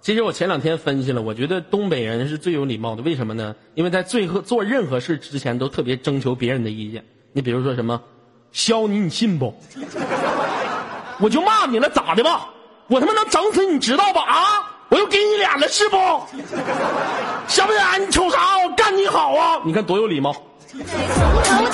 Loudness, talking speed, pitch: -19 LUFS, 280 characters per minute, 200 Hz